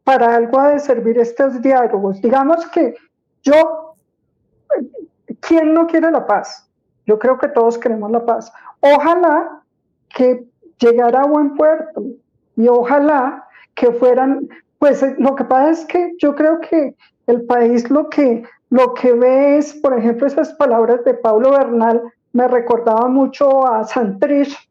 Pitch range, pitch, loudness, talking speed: 240-295 Hz, 270 Hz, -14 LUFS, 145 wpm